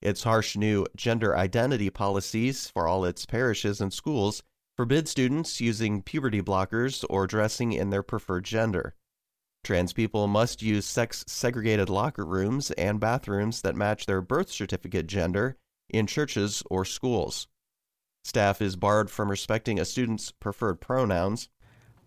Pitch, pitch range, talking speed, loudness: 105 Hz, 100-115 Hz, 140 wpm, -28 LUFS